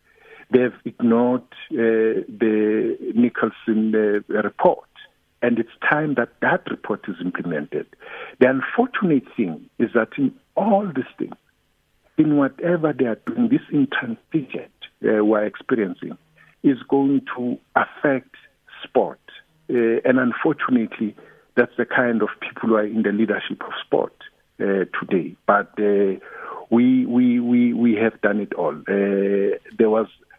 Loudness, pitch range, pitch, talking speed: -21 LUFS, 110-175 Hz, 120 Hz, 140 wpm